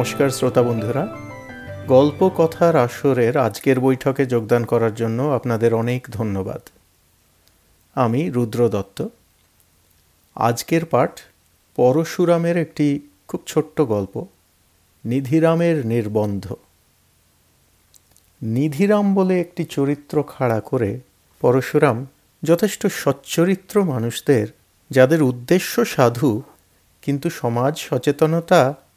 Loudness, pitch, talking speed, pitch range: -19 LUFS, 125 Hz, 85 wpm, 105-155 Hz